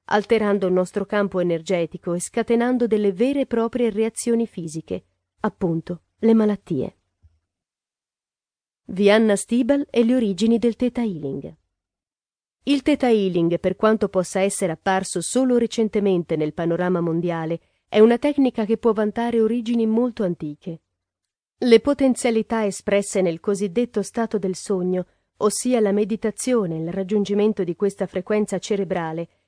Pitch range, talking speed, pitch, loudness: 175-230 Hz, 130 wpm, 205 Hz, -21 LUFS